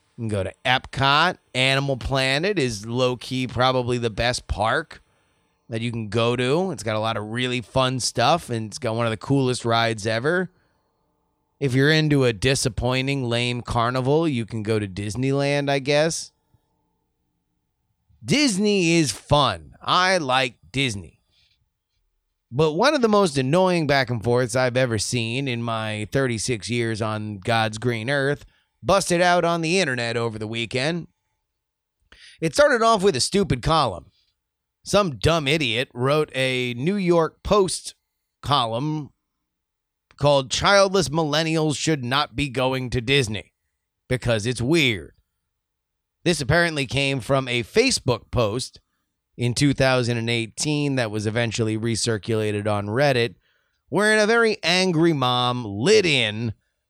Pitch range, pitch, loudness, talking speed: 115-150 Hz, 130 Hz, -22 LUFS, 140 wpm